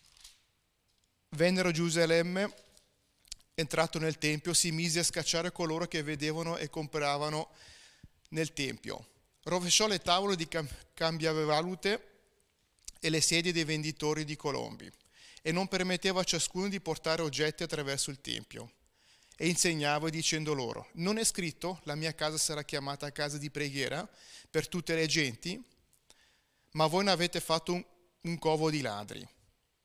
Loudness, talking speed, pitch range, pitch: -32 LUFS, 140 wpm, 150-175 Hz, 160 Hz